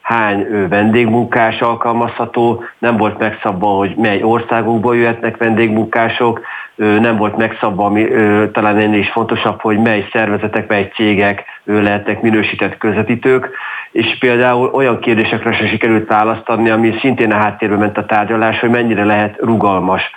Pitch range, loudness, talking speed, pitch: 105-115 Hz, -13 LUFS, 135 wpm, 110 Hz